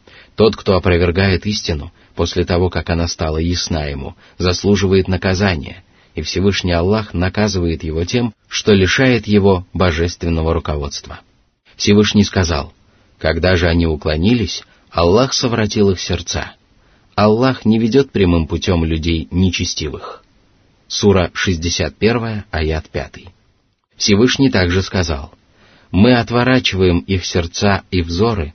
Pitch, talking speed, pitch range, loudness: 95 Hz, 115 wpm, 85-105 Hz, -16 LUFS